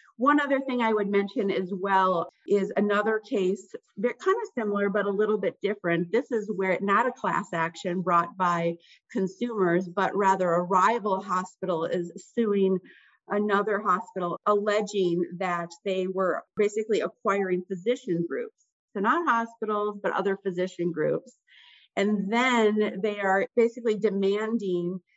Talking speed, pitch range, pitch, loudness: 145 wpm, 185-220 Hz, 200 Hz, -27 LUFS